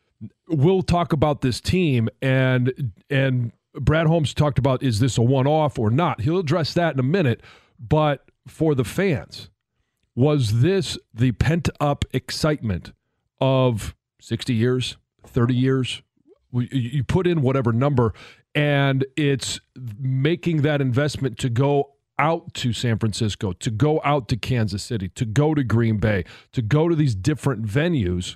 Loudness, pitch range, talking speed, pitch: -22 LUFS, 120-150 Hz, 150 wpm, 130 Hz